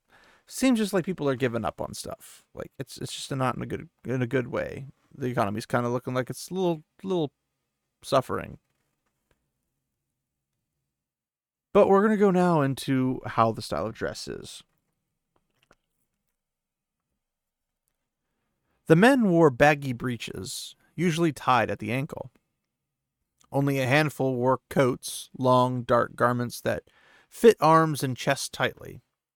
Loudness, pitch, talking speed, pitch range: -25 LUFS, 135 Hz, 140 wpm, 125-170 Hz